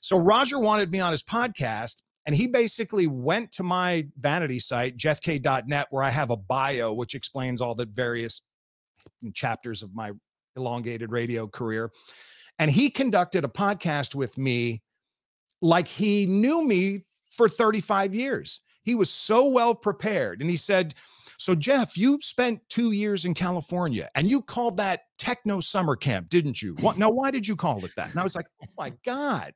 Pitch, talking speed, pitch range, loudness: 175 Hz, 175 wpm, 130-215 Hz, -25 LUFS